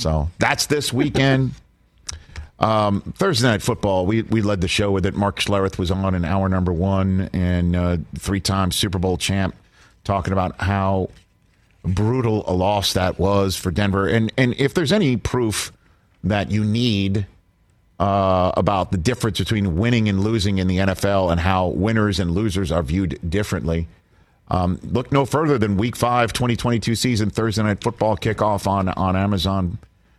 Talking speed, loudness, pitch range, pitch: 165 wpm, -20 LUFS, 95-110 Hz, 100 Hz